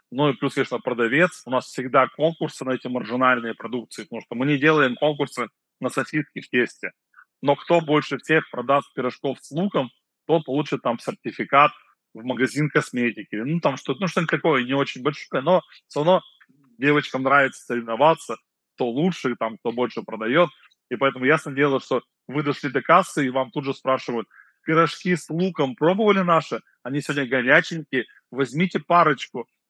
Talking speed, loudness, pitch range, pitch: 170 wpm, -22 LUFS, 125-155 Hz, 140 Hz